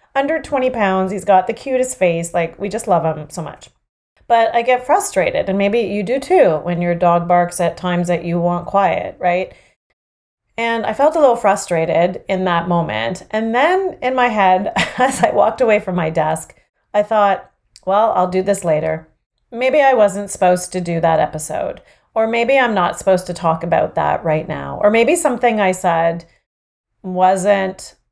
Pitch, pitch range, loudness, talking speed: 190 Hz, 175-230 Hz, -16 LUFS, 190 wpm